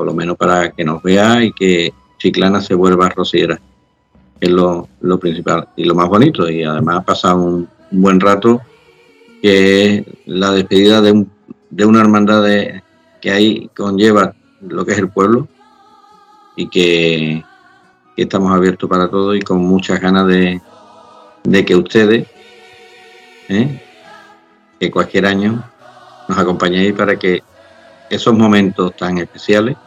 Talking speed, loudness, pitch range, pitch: 145 wpm, -13 LUFS, 90-105 Hz, 95 Hz